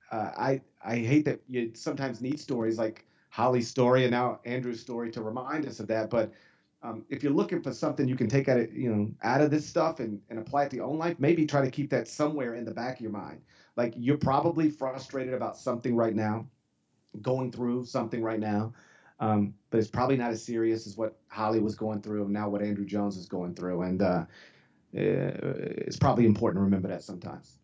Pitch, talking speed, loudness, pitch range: 120 Hz, 220 wpm, -30 LUFS, 110-135 Hz